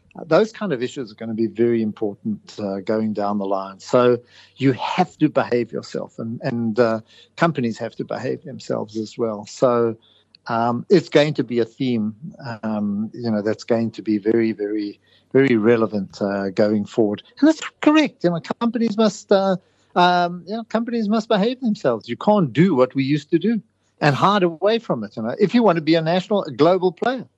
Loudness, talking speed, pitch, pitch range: -20 LUFS, 205 wpm, 125 Hz, 110-185 Hz